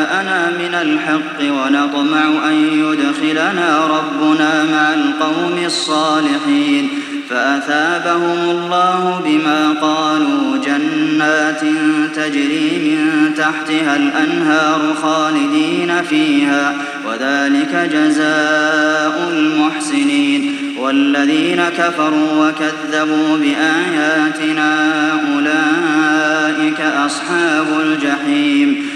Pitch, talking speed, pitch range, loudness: 155 Hz, 60 wpm, 155-175 Hz, -14 LUFS